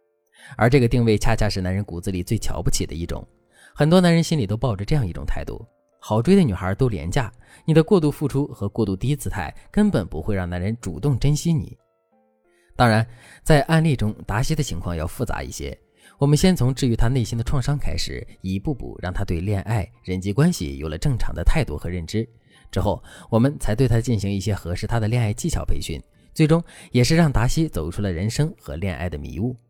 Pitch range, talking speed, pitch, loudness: 95-145 Hz, 320 characters per minute, 115 Hz, -22 LUFS